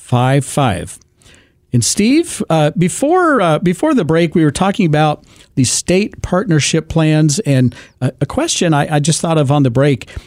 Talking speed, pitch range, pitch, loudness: 175 wpm, 140-180 Hz, 155 Hz, -14 LUFS